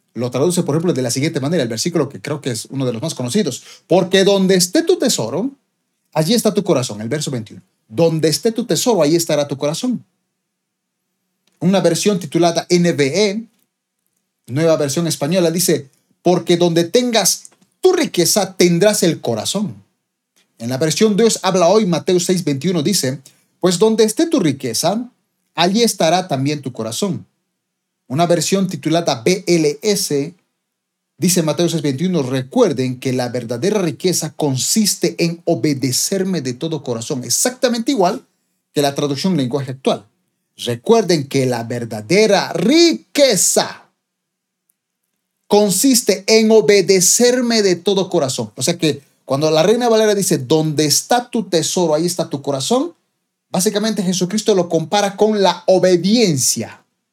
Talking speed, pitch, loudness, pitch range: 140 wpm, 175 Hz, -16 LUFS, 150-205 Hz